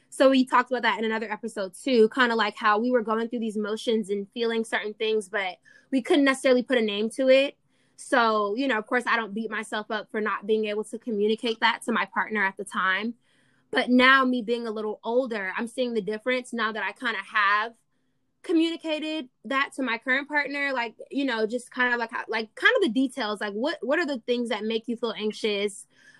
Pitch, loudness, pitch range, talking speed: 230 Hz, -25 LUFS, 215-260 Hz, 235 wpm